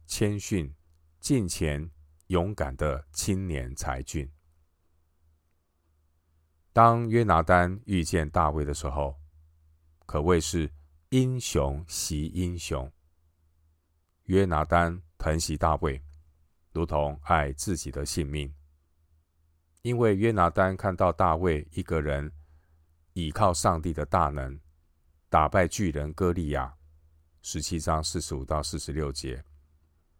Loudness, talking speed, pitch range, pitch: -28 LUFS, 165 characters per minute, 75-90 Hz, 80 Hz